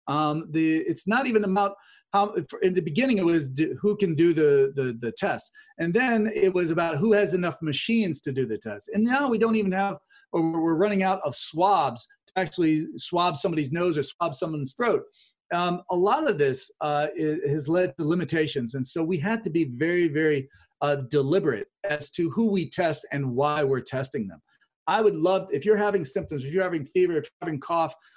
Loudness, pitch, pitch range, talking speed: -25 LUFS, 175 Hz, 155-200 Hz, 215 wpm